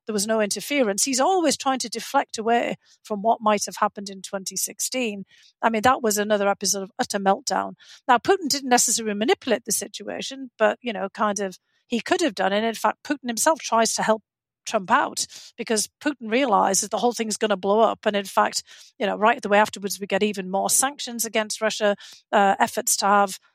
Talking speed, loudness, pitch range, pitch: 210 wpm, -23 LUFS, 205-240 Hz, 215 Hz